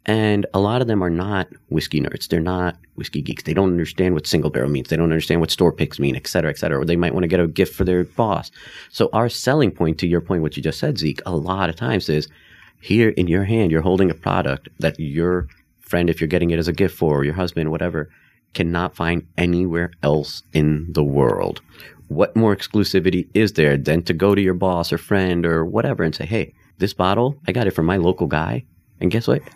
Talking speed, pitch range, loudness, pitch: 240 wpm, 80-95 Hz, -20 LUFS, 90 Hz